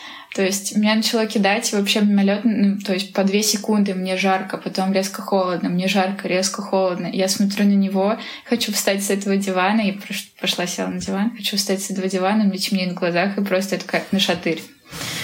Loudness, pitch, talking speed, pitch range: -20 LUFS, 195 Hz, 205 wpm, 190-205 Hz